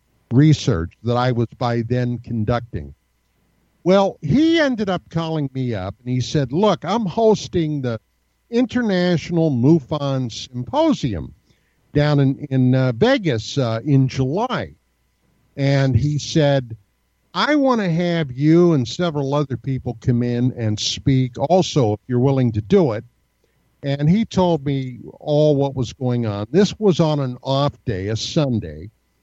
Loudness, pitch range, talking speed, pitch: -19 LUFS, 120-165 Hz, 150 wpm, 135 Hz